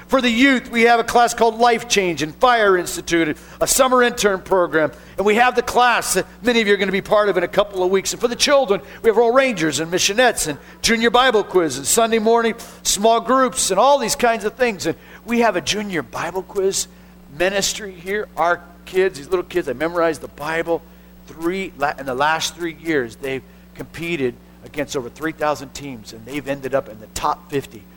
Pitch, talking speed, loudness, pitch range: 185 Hz, 215 wpm, -18 LUFS, 160-230 Hz